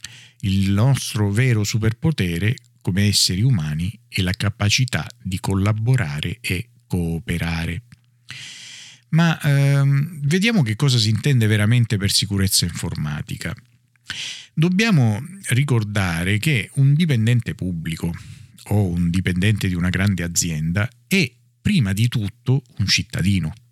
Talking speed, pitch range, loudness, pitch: 110 wpm, 95-130 Hz, -20 LUFS, 115 Hz